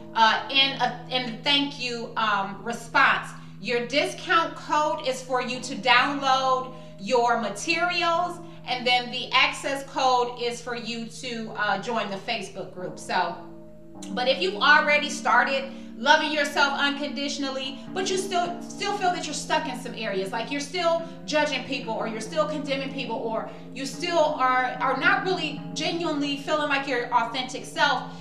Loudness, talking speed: -24 LUFS, 160 wpm